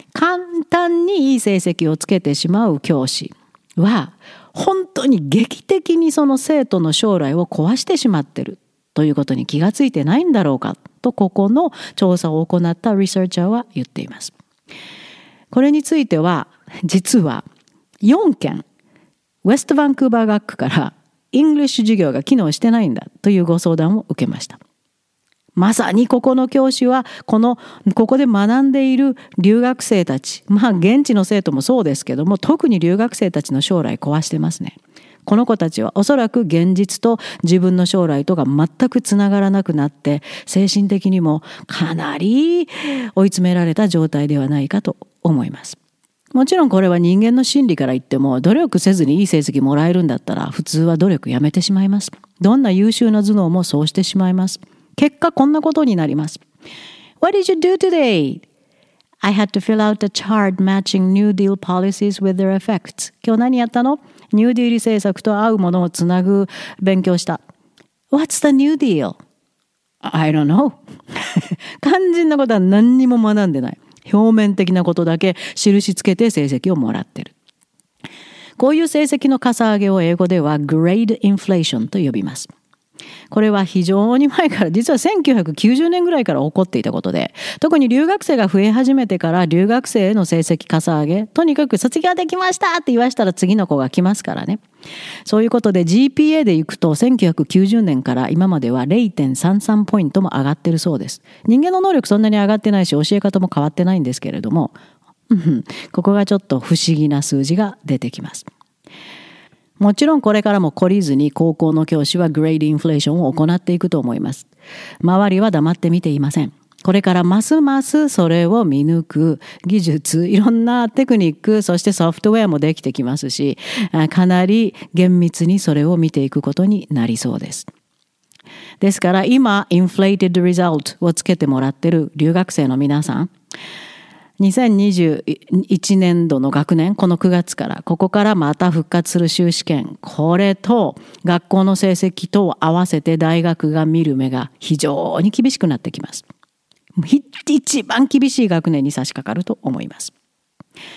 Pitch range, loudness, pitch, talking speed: 165-235 Hz, -16 LUFS, 195 Hz, 360 characters per minute